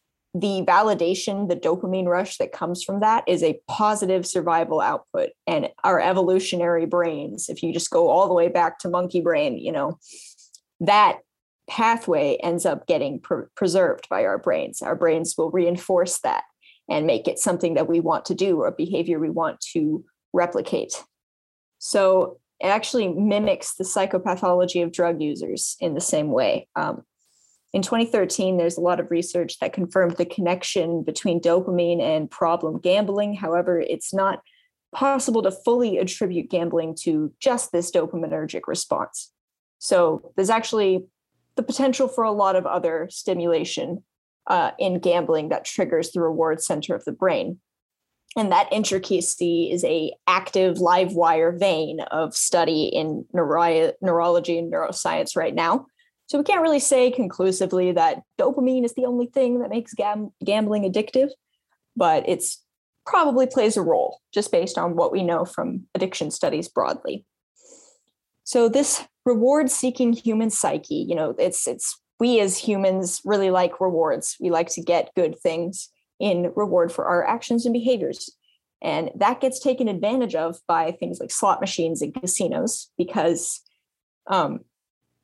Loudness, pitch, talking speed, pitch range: -22 LUFS, 185 Hz, 155 wpm, 170-230 Hz